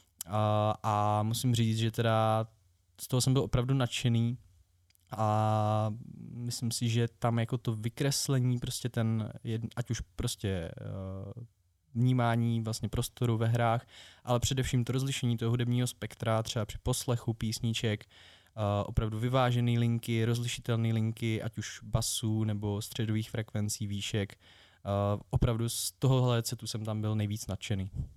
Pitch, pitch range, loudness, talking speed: 115 Hz, 105-120 Hz, -32 LUFS, 140 wpm